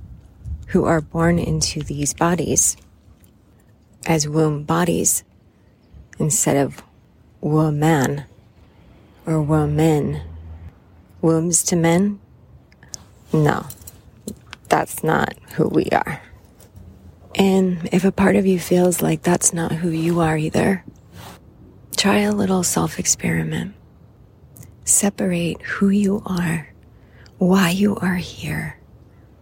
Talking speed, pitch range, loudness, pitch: 105 wpm, 105-175 Hz, -19 LUFS, 155 Hz